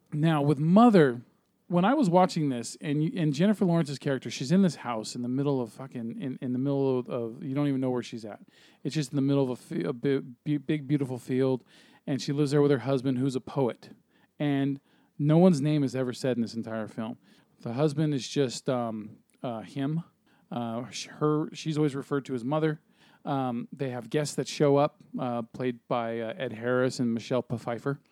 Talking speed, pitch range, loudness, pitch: 210 wpm, 125-150 Hz, -28 LUFS, 140 Hz